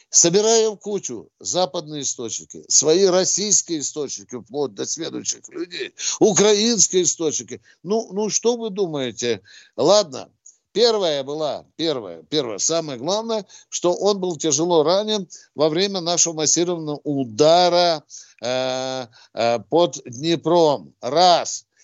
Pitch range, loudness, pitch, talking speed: 140-200 Hz, -20 LUFS, 170 Hz, 110 wpm